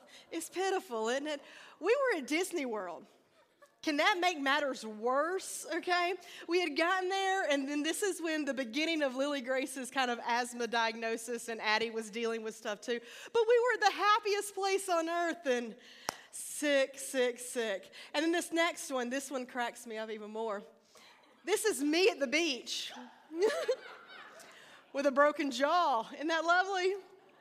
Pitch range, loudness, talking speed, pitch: 245-360 Hz, -33 LUFS, 170 wpm, 290 Hz